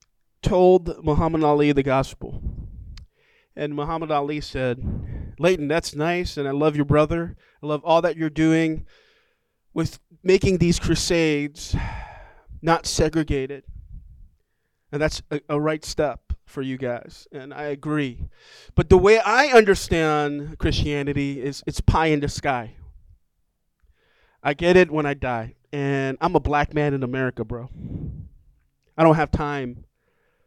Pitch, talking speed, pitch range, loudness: 145 Hz, 140 wpm, 130-160 Hz, -22 LUFS